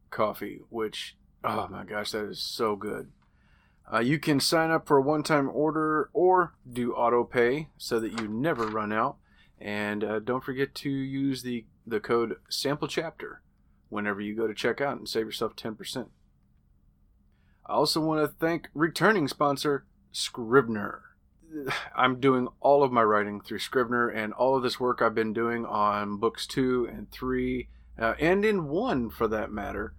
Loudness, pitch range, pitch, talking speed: -28 LUFS, 110-140 Hz, 125 Hz, 170 wpm